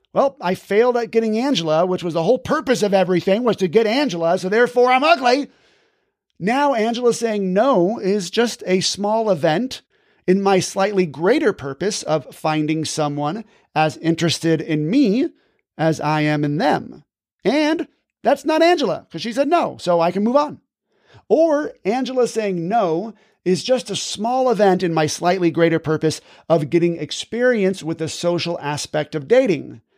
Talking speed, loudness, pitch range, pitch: 165 wpm, -19 LUFS, 165-245 Hz, 195 Hz